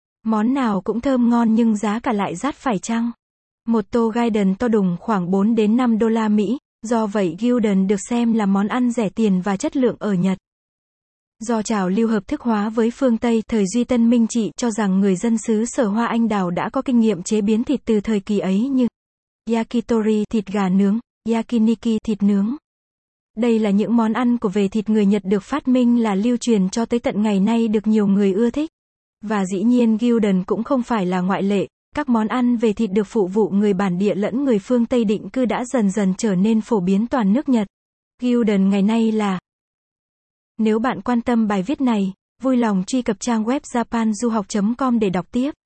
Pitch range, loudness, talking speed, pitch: 205-240 Hz, -19 LUFS, 220 wpm, 225 Hz